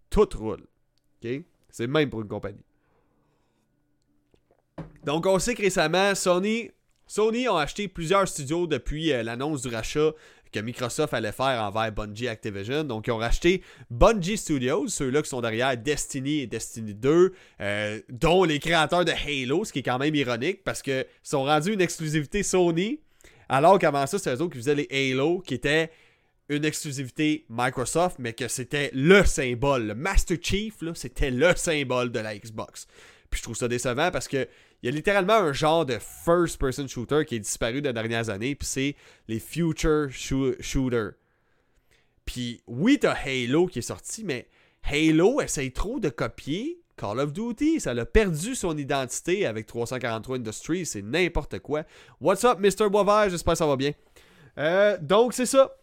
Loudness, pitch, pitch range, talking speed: -25 LUFS, 145 Hz, 125-175 Hz, 170 wpm